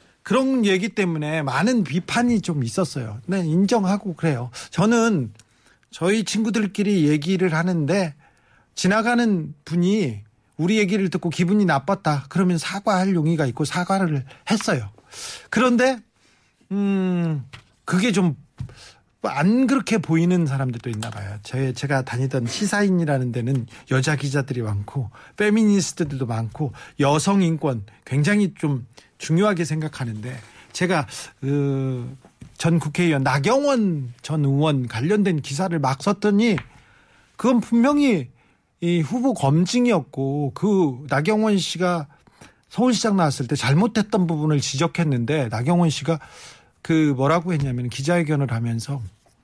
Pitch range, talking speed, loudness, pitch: 135-195 Hz, 280 characters per minute, -21 LUFS, 160 Hz